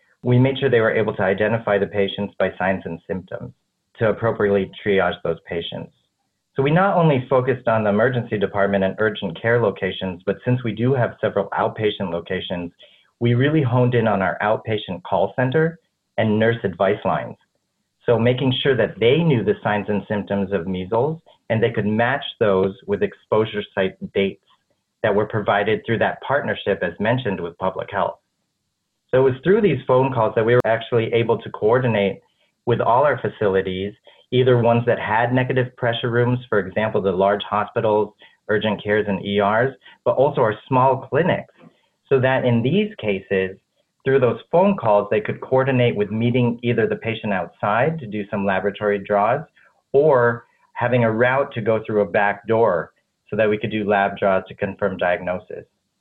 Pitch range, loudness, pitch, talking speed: 100-125 Hz, -20 LUFS, 110 Hz, 180 wpm